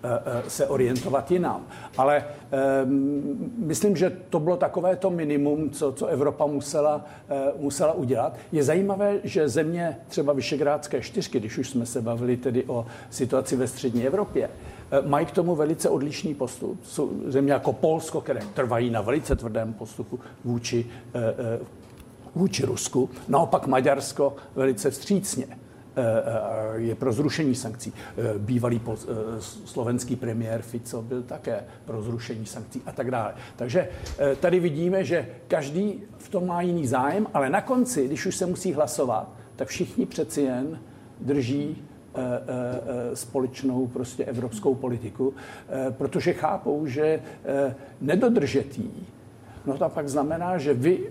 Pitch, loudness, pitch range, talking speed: 140 Hz, -26 LUFS, 125-160 Hz, 135 wpm